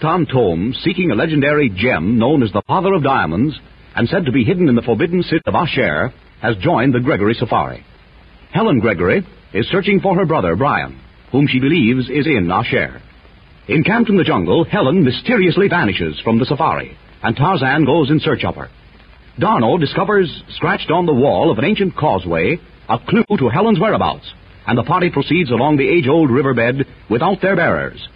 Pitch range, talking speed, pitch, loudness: 120-180 Hz, 180 wpm, 150 Hz, -15 LUFS